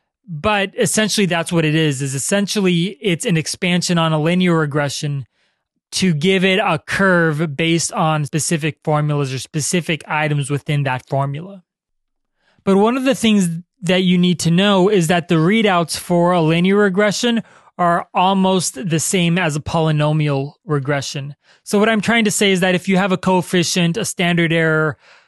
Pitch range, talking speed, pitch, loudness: 155-190 Hz, 170 wpm, 175 Hz, -17 LUFS